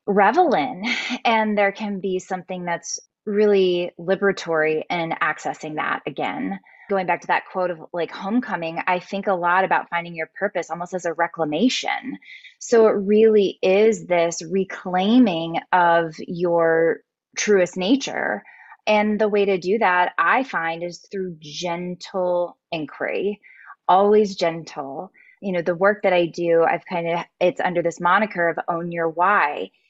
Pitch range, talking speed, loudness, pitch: 170-205 Hz, 155 wpm, -21 LUFS, 180 Hz